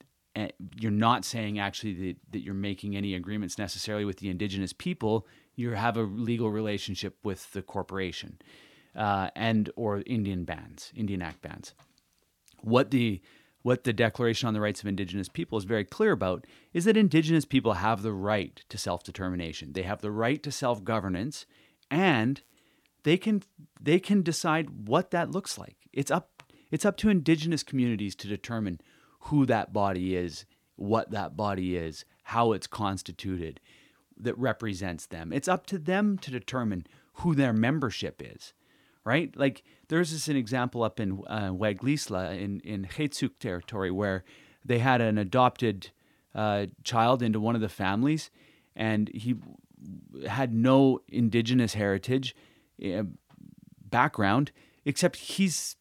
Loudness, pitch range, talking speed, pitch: -29 LUFS, 100-135 Hz, 155 wpm, 110 Hz